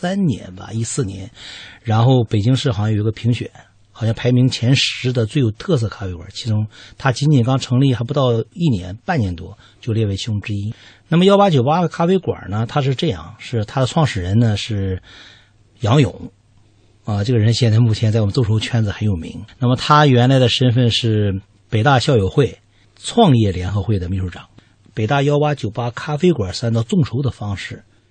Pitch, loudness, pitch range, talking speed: 115 Hz, -17 LUFS, 105-130 Hz, 290 characters per minute